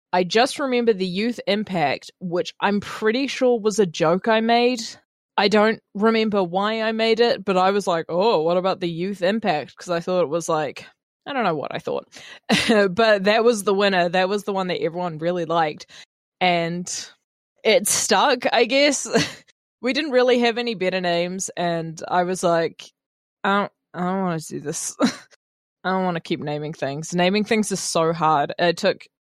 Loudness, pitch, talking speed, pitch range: -21 LUFS, 190 Hz, 195 wpm, 175-220 Hz